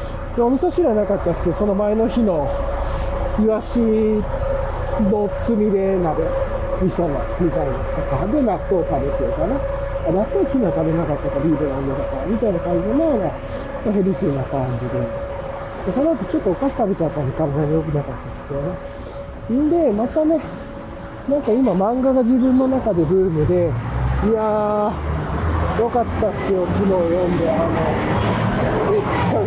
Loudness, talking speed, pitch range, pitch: -20 LUFS, 325 characters per minute, 160-240 Hz, 200 Hz